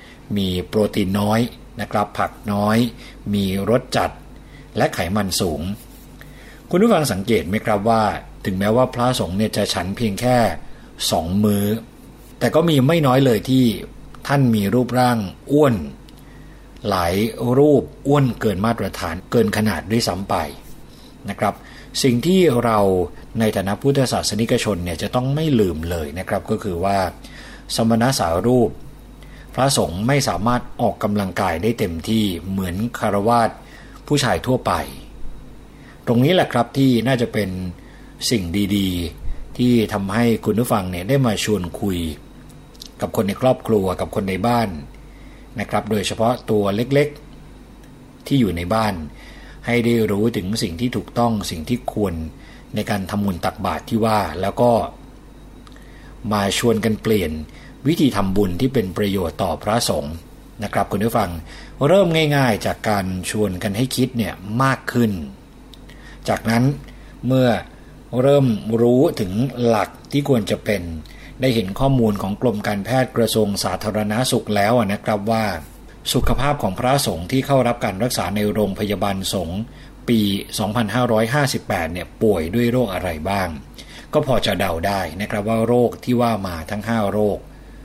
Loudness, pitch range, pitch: -20 LUFS, 100-125 Hz, 110 Hz